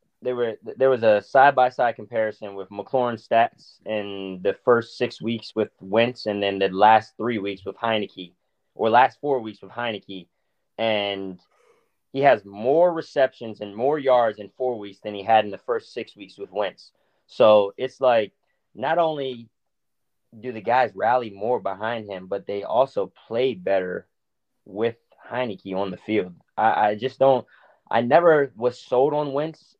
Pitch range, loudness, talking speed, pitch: 100-130 Hz, -23 LUFS, 175 wpm, 115 Hz